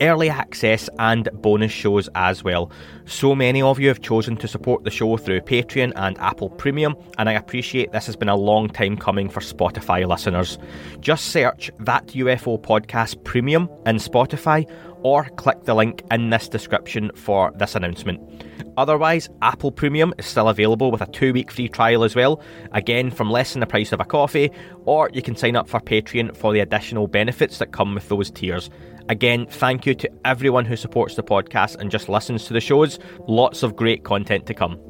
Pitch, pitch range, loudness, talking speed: 115 Hz, 105-130 Hz, -20 LUFS, 195 wpm